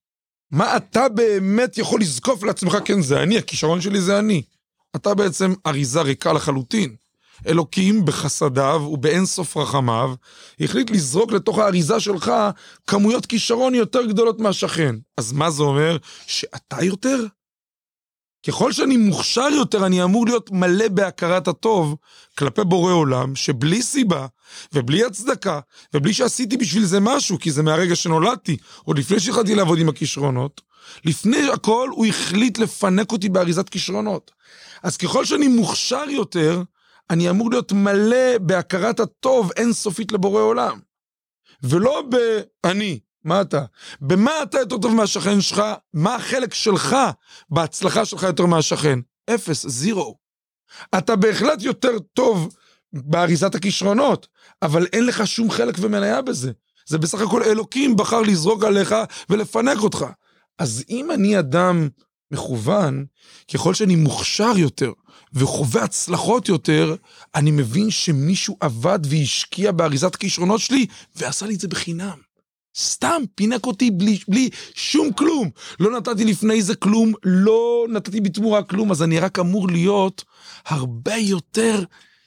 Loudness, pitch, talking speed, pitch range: -19 LUFS, 195 Hz, 135 wpm, 165-225 Hz